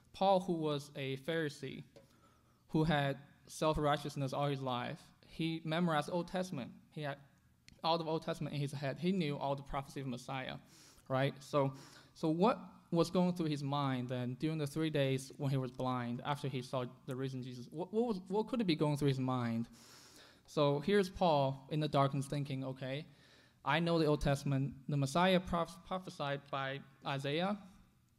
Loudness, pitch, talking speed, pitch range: -37 LUFS, 145 Hz, 185 wpm, 135-165 Hz